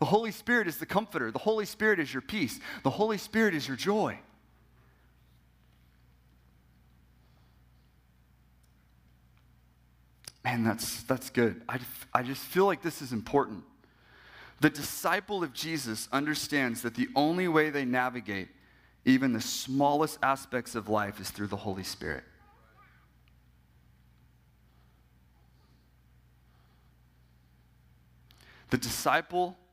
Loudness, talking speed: -30 LUFS, 110 wpm